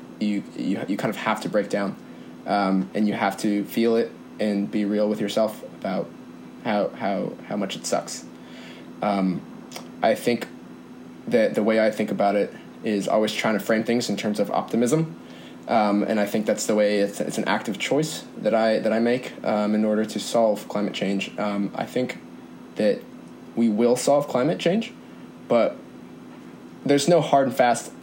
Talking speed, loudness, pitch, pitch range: 185 wpm, -24 LUFS, 105 Hz, 100-110 Hz